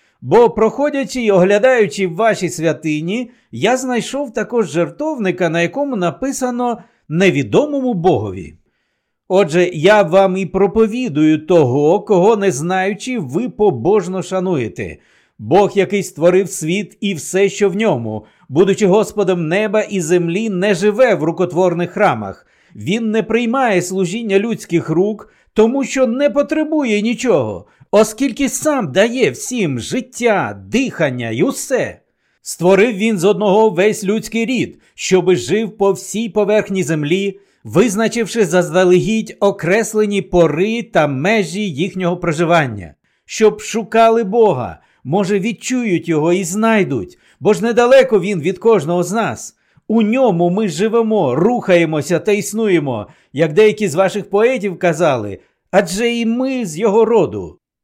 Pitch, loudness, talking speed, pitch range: 200 Hz, -15 LUFS, 125 wpm, 180-225 Hz